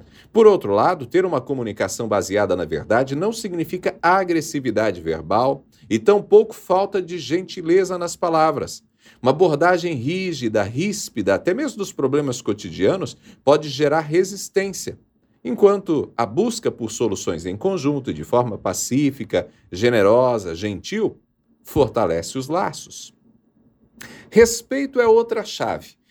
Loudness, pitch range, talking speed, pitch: -20 LUFS, 135-195 Hz, 120 wpm, 175 Hz